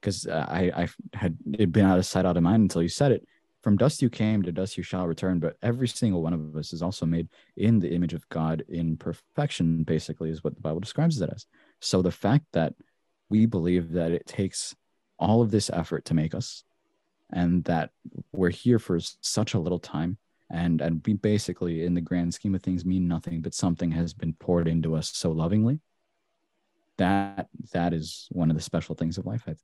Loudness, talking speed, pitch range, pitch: -27 LUFS, 215 wpm, 85-105 Hz, 90 Hz